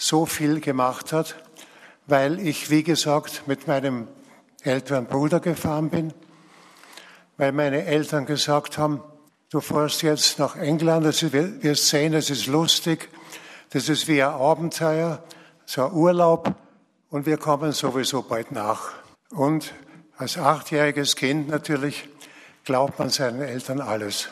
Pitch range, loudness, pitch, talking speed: 140-160 Hz, -23 LUFS, 150 Hz, 130 wpm